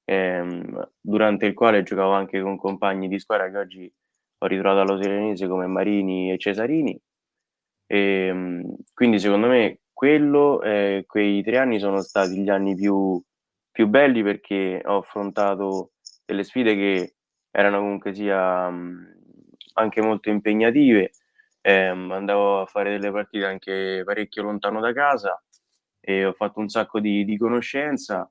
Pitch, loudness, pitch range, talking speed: 100 Hz, -22 LUFS, 95-105 Hz, 135 wpm